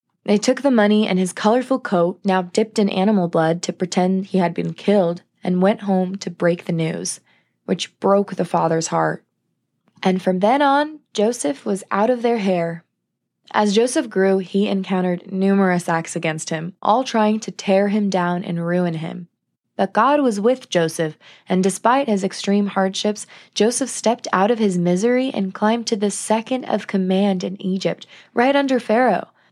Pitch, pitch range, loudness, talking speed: 195 Hz, 180-220 Hz, -19 LUFS, 175 wpm